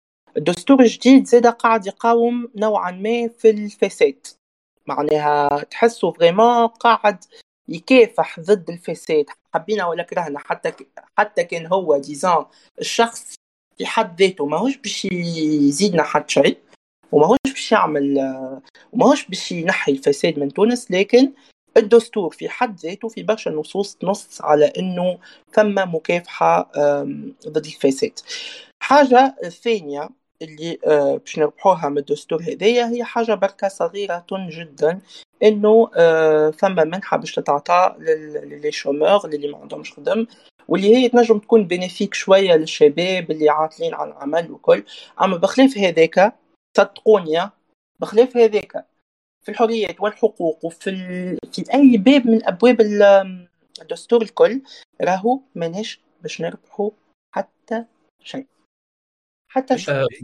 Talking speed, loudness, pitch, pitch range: 125 wpm, -18 LUFS, 205 Hz, 165-235 Hz